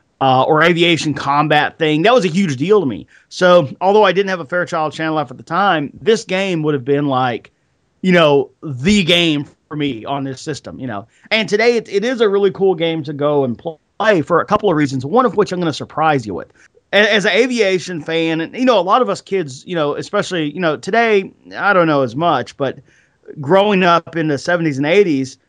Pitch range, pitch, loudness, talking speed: 145-195 Hz, 165 Hz, -15 LUFS, 235 wpm